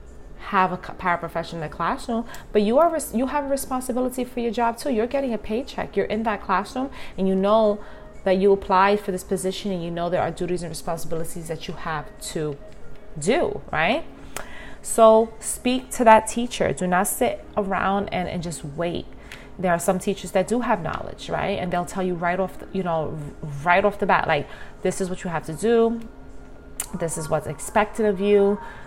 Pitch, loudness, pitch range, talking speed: 190 Hz, -23 LUFS, 170-220 Hz, 200 wpm